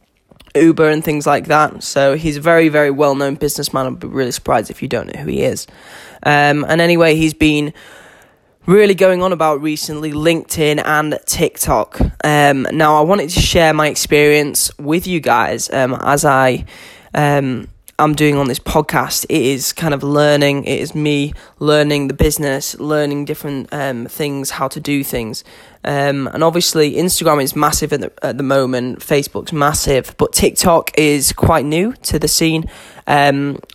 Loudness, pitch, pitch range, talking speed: -14 LUFS, 150 Hz, 140-155 Hz, 175 wpm